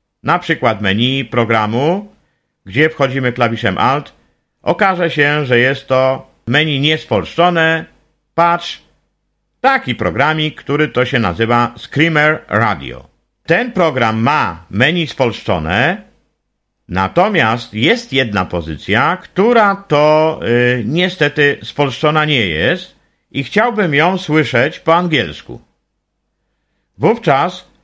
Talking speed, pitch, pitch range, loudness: 100 wpm, 140 Hz, 120-160 Hz, -14 LUFS